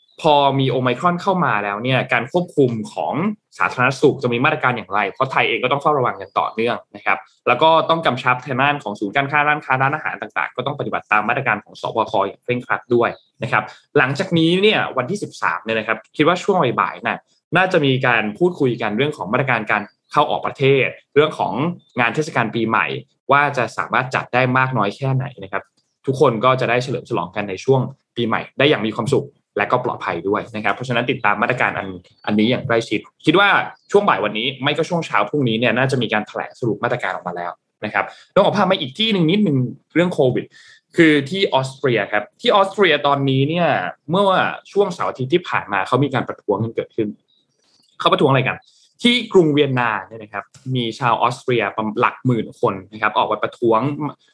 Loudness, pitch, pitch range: -18 LUFS, 130 Hz, 115-155 Hz